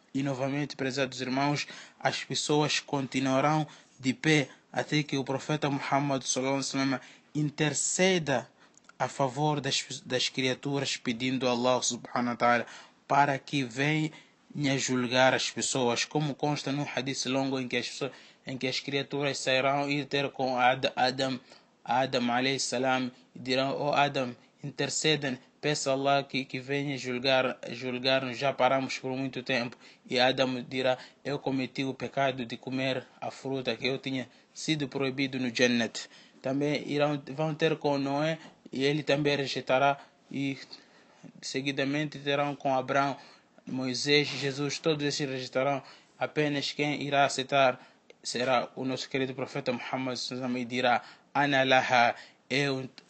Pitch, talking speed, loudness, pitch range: 135 Hz, 140 wpm, -29 LUFS, 130-140 Hz